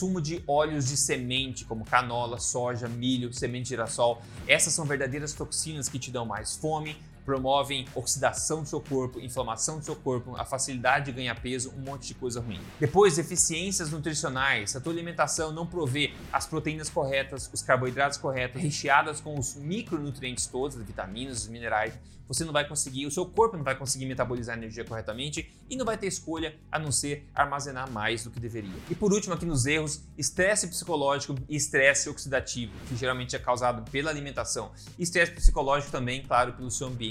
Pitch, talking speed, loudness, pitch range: 135 Hz, 185 wpm, -29 LUFS, 125-155 Hz